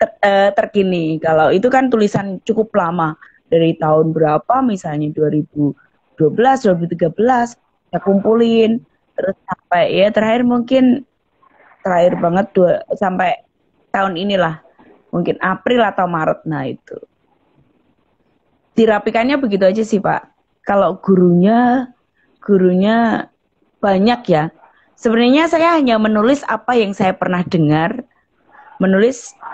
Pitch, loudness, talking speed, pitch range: 205 Hz, -15 LUFS, 110 wpm, 180-240 Hz